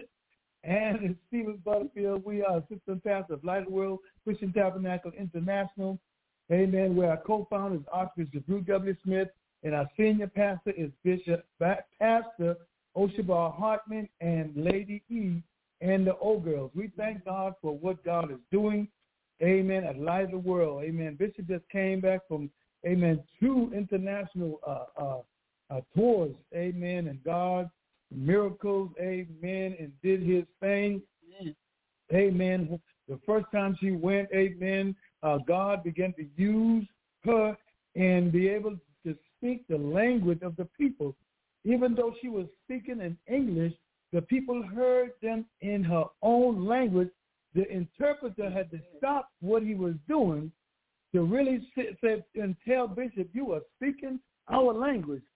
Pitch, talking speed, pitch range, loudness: 190 Hz, 150 wpm, 175-215 Hz, -30 LUFS